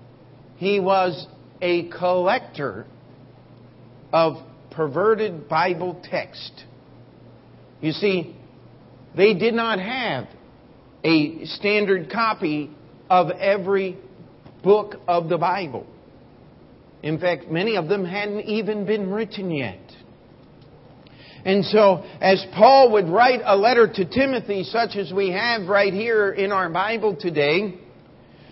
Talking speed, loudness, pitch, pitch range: 110 wpm, -21 LUFS, 185 Hz, 155-205 Hz